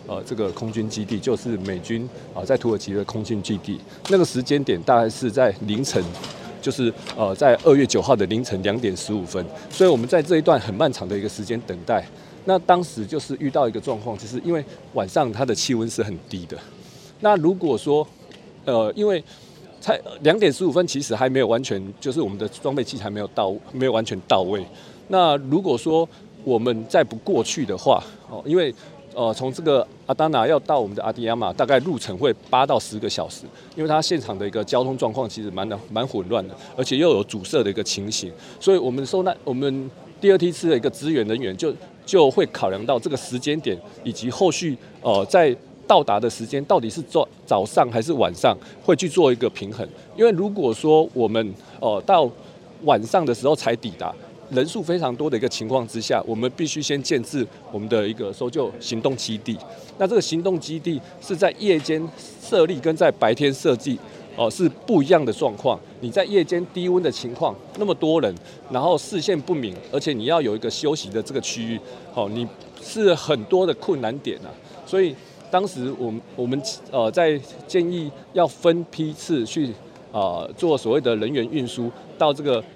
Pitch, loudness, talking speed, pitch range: 130 Hz, -22 LUFS, 300 characters per minute, 115-165 Hz